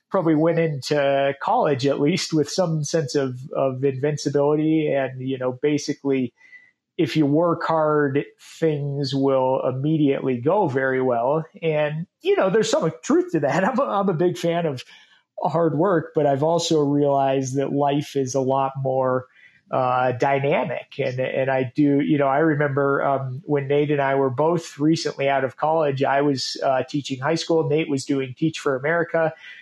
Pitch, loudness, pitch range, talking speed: 145 Hz, -22 LUFS, 135-160 Hz, 175 wpm